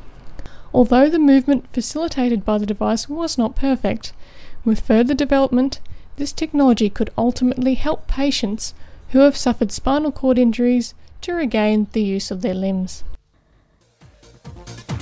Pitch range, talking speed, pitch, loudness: 215-275 Hz, 130 wpm, 245 Hz, -18 LUFS